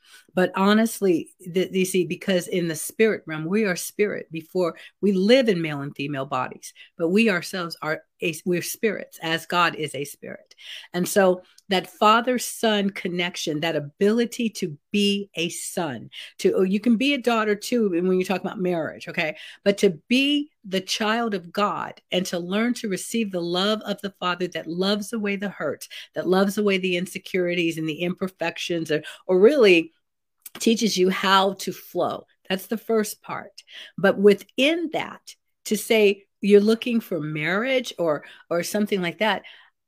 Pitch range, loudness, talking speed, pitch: 175-215 Hz, -23 LUFS, 170 wpm, 190 Hz